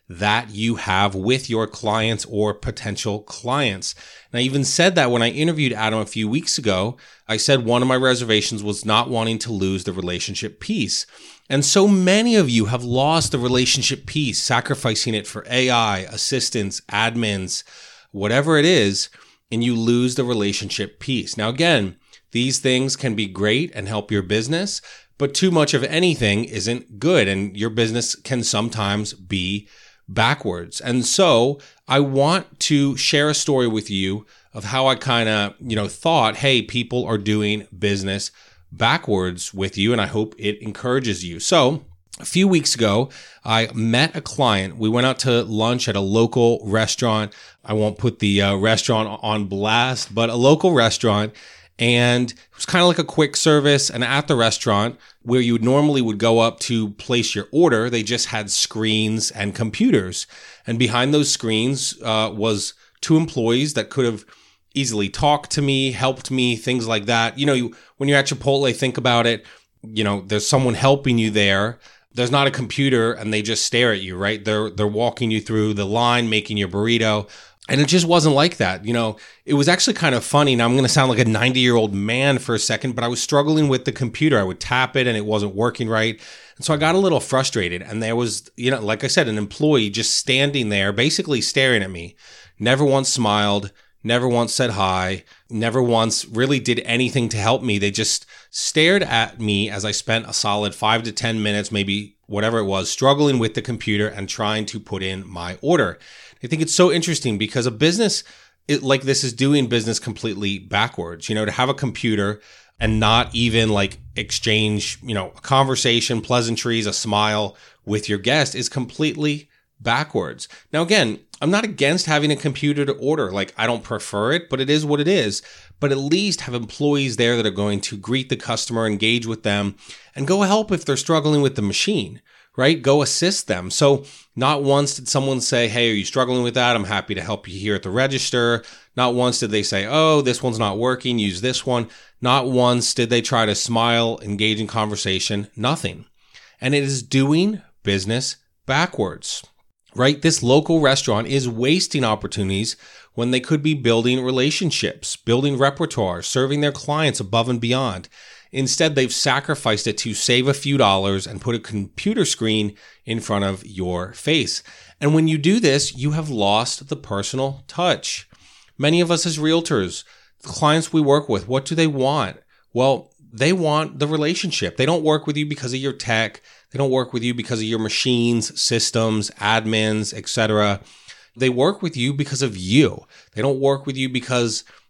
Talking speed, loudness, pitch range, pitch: 190 wpm, -19 LUFS, 105-135 Hz, 120 Hz